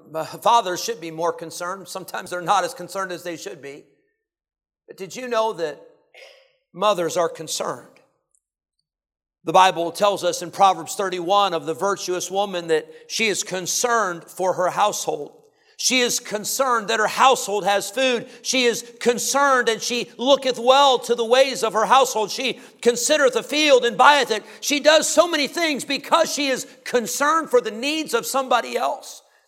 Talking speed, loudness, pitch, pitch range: 170 wpm, -20 LUFS, 235 Hz, 190-265 Hz